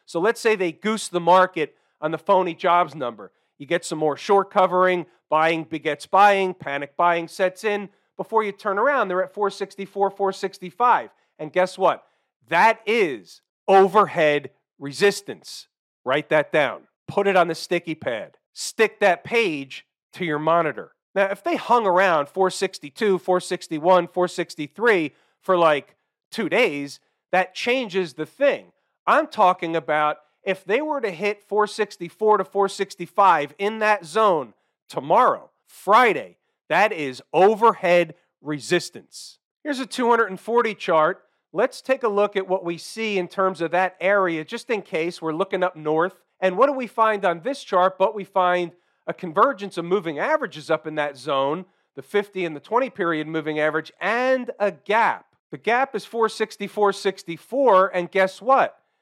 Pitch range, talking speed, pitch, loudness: 170-210 Hz, 155 wpm, 190 Hz, -22 LUFS